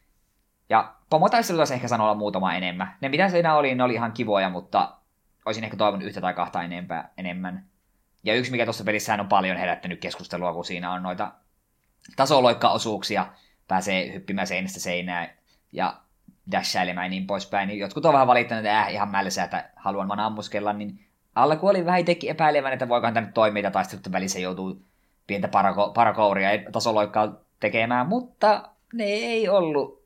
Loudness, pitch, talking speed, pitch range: -24 LUFS, 105 Hz, 160 wpm, 95-125 Hz